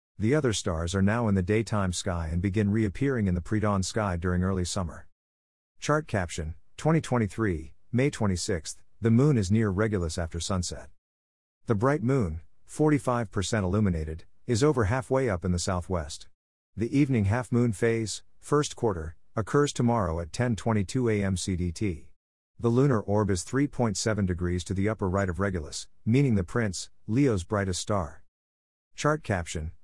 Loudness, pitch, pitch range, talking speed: -28 LUFS, 100 Hz, 85-115 Hz, 155 wpm